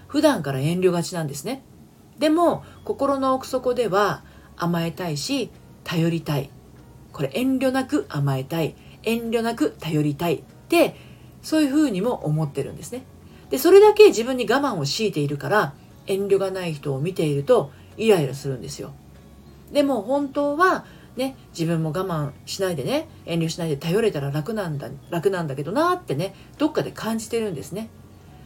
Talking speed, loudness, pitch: 335 characters per minute, -23 LUFS, 180 Hz